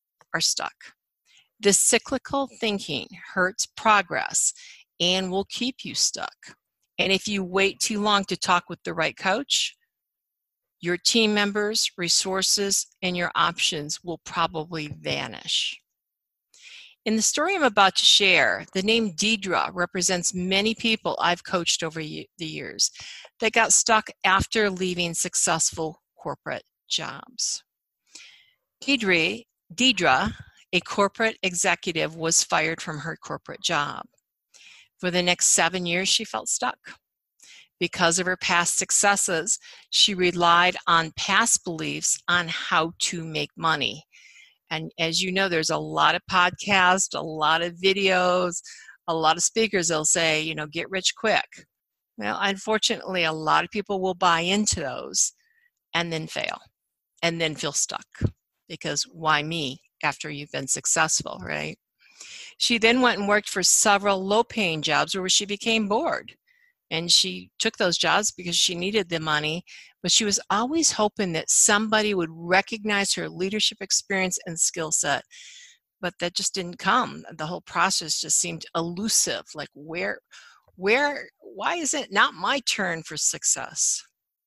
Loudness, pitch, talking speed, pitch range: -23 LUFS, 185 Hz, 145 wpm, 170-210 Hz